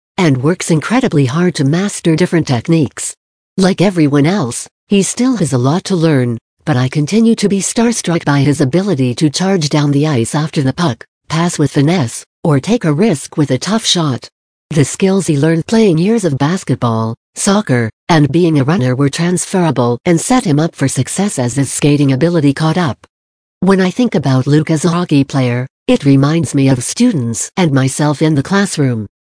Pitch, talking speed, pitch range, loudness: 155 Hz, 190 wpm, 140-180 Hz, -13 LUFS